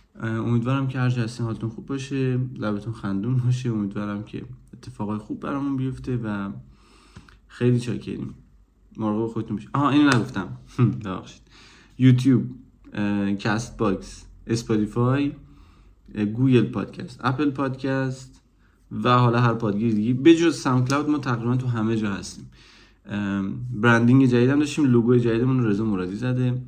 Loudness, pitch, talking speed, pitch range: -23 LUFS, 120 Hz, 125 wpm, 105-130 Hz